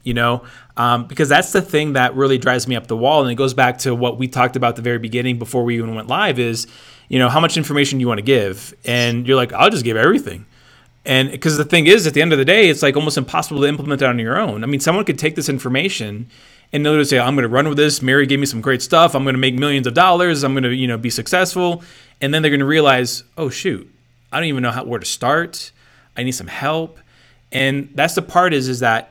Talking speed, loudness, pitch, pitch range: 280 wpm, -16 LUFS, 135 Hz, 120-150 Hz